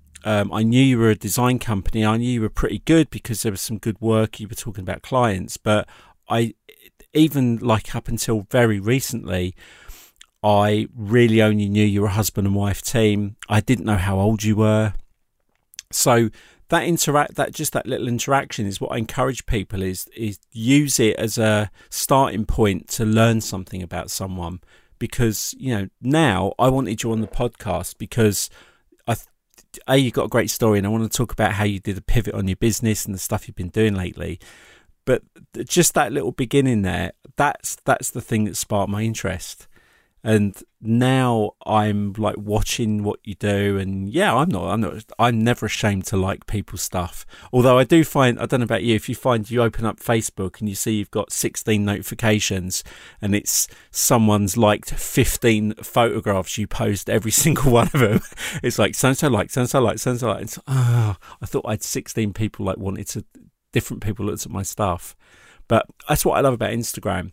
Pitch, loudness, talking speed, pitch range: 110 Hz, -21 LUFS, 200 wpm, 100-120 Hz